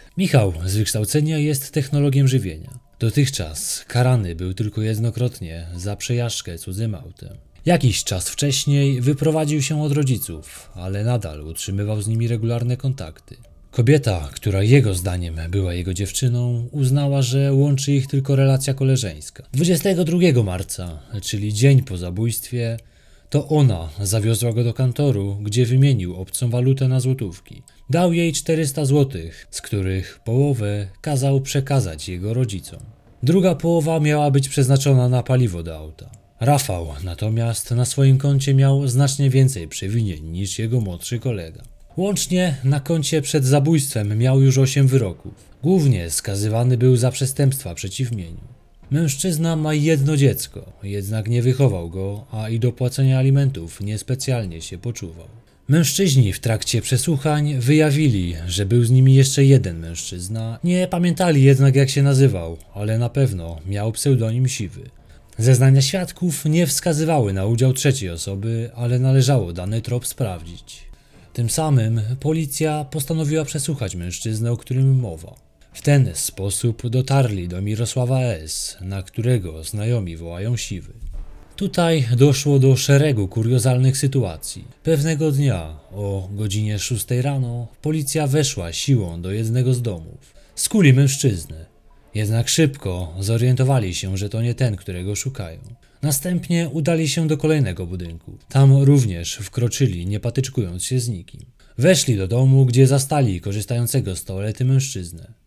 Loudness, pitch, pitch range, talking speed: -19 LUFS, 125 Hz, 100-140 Hz, 135 wpm